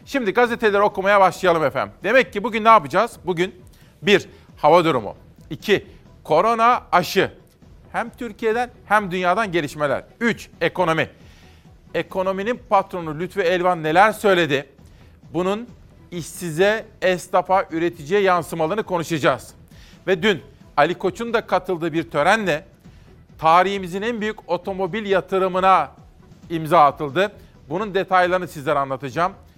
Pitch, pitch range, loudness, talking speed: 185 Hz, 170-210 Hz, -20 LUFS, 110 wpm